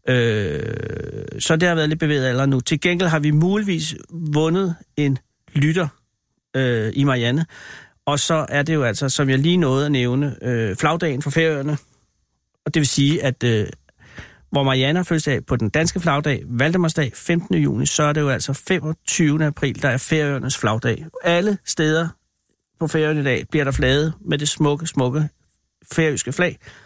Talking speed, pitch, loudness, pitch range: 175 wpm, 145 Hz, -20 LUFS, 130-160 Hz